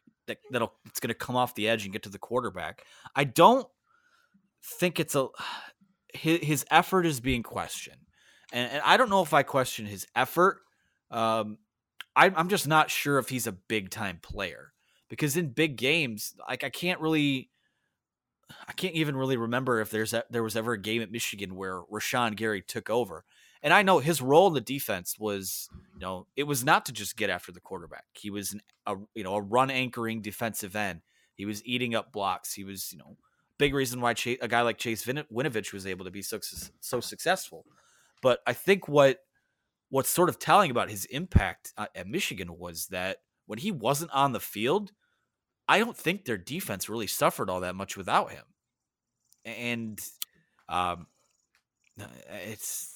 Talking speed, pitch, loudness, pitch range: 185 wpm, 120 Hz, -28 LUFS, 105-140 Hz